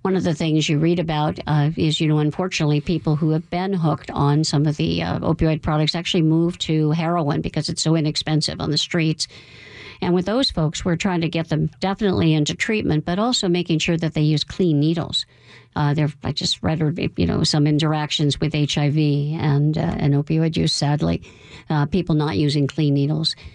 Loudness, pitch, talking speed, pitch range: -20 LUFS, 155 Hz, 200 wpm, 150-165 Hz